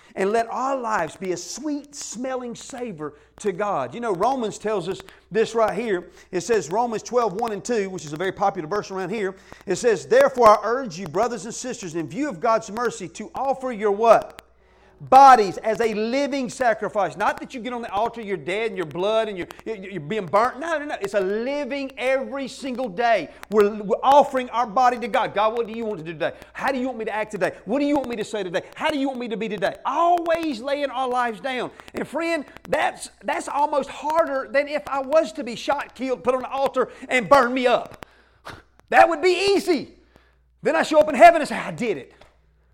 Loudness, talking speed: -22 LUFS, 230 wpm